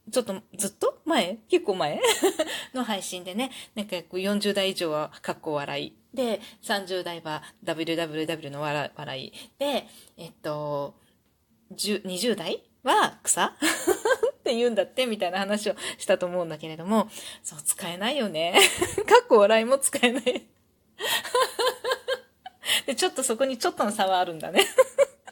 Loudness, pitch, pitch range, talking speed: -26 LUFS, 215 Hz, 180-305 Hz, 255 characters per minute